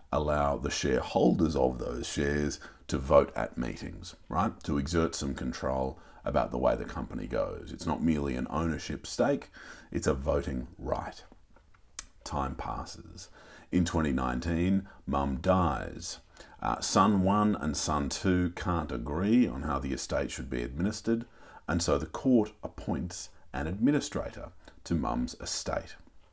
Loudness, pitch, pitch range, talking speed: -31 LUFS, 80 Hz, 70-90 Hz, 140 wpm